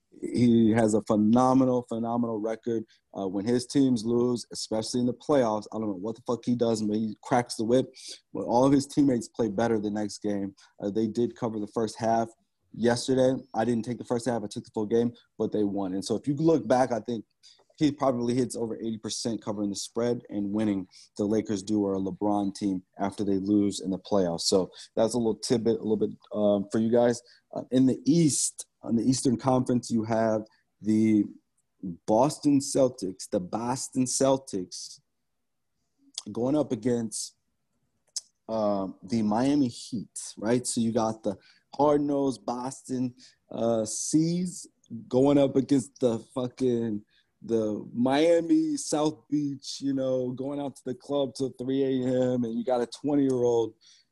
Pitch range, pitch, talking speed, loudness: 110-130 Hz, 120 Hz, 180 wpm, -27 LUFS